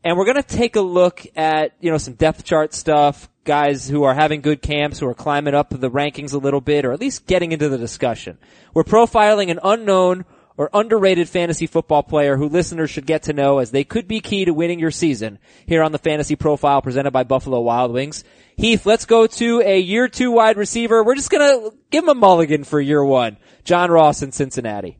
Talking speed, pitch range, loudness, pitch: 220 wpm, 145-195 Hz, -17 LUFS, 155 Hz